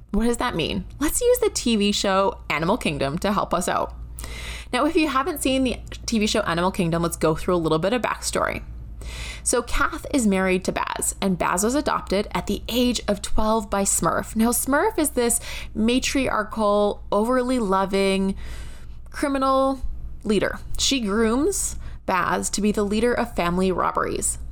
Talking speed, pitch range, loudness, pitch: 170 wpm, 185-250 Hz, -22 LUFS, 210 Hz